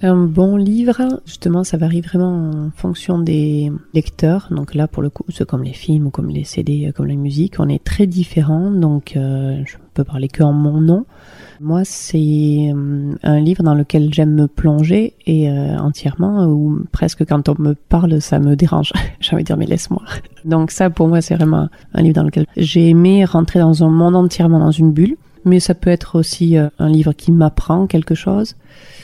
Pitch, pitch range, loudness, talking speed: 160 Hz, 150-175 Hz, -15 LUFS, 205 wpm